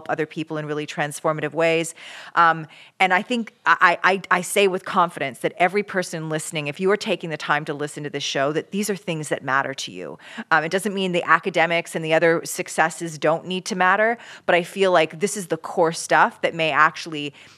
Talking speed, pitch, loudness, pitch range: 220 wpm, 165 Hz, -21 LUFS, 155-185 Hz